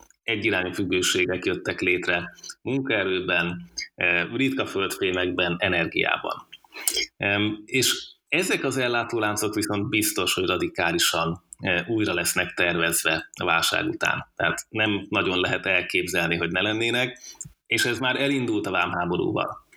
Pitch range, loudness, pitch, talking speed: 90-115 Hz, -24 LUFS, 105 Hz, 110 wpm